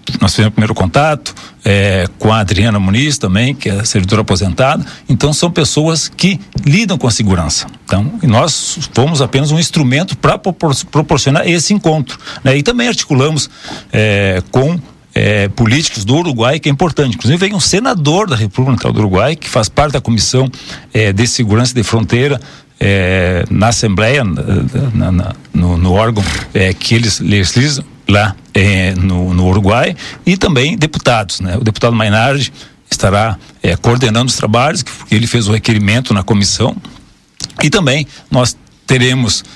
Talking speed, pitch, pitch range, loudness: 160 wpm, 120 Hz, 105-145 Hz, -12 LUFS